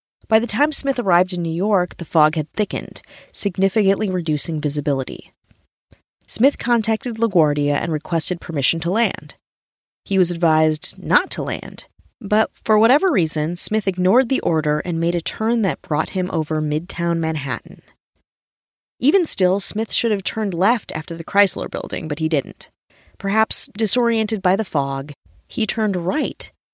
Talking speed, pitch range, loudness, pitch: 155 wpm, 160-220 Hz, -19 LUFS, 185 Hz